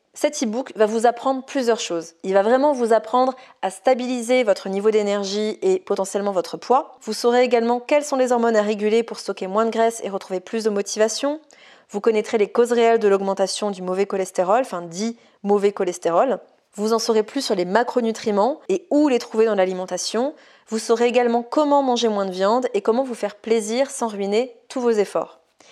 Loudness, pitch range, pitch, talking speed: -21 LUFS, 200-245 Hz, 225 Hz, 200 wpm